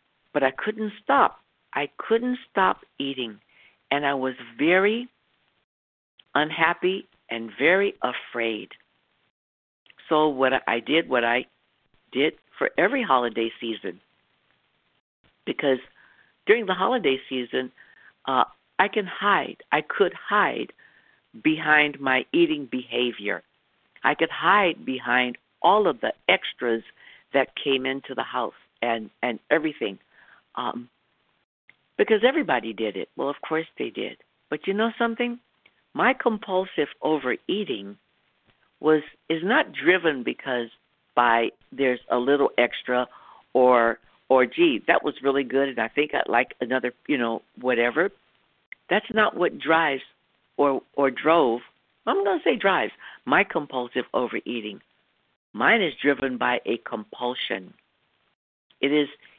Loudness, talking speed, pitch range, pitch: -24 LUFS, 125 wpm, 120-180 Hz, 135 Hz